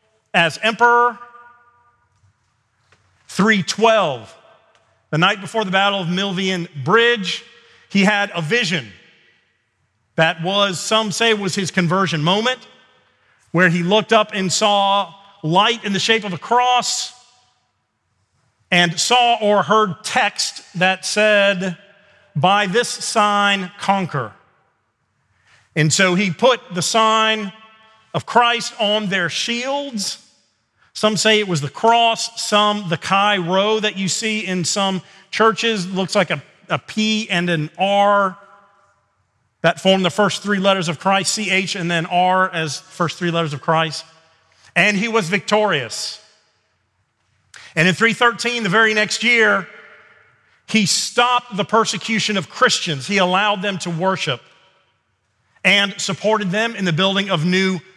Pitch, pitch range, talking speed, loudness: 195 Hz, 170-220 Hz, 135 wpm, -17 LUFS